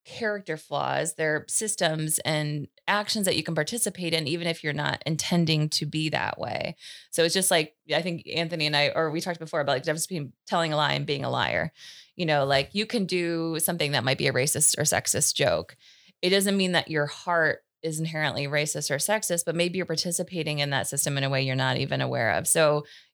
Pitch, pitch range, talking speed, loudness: 160 Hz, 150-175 Hz, 225 wpm, -26 LUFS